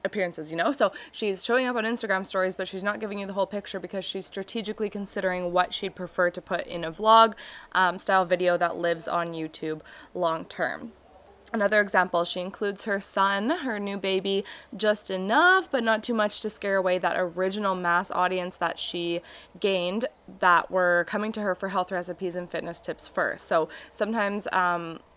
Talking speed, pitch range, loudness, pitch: 190 wpm, 180-205 Hz, -26 LUFS, 190 Hz